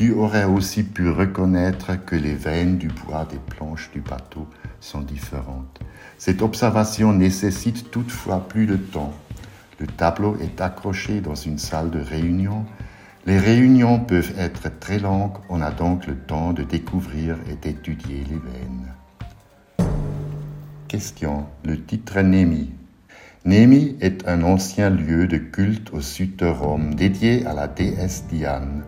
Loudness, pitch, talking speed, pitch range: -21 LUFS, 90 Hz, 140 wpm, 80-105 Hz